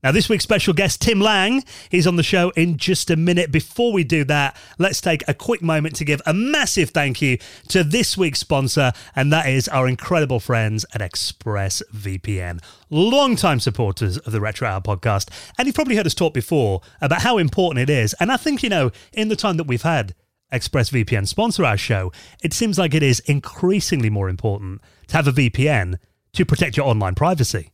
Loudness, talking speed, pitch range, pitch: -19 LUFS, 200 wpm, 110-180 Hz, 145 Hz